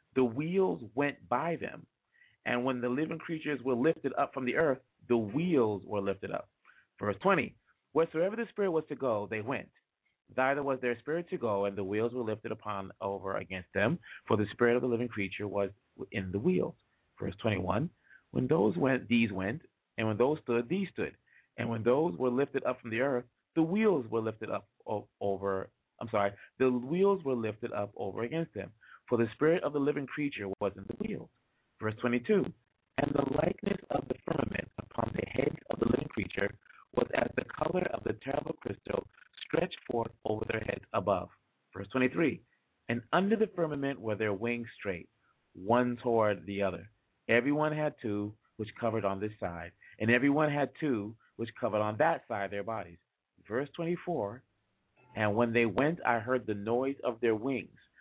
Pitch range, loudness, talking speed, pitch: 105-140 Hz, -33 LUFS, 190 wpm, 120 Hz